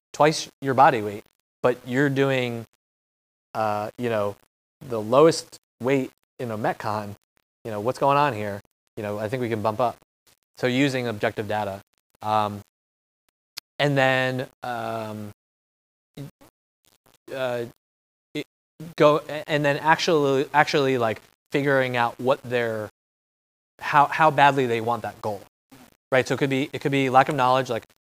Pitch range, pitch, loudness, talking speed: 105-140 Hz, 125 Hz, -23 LUFS, 150 wpm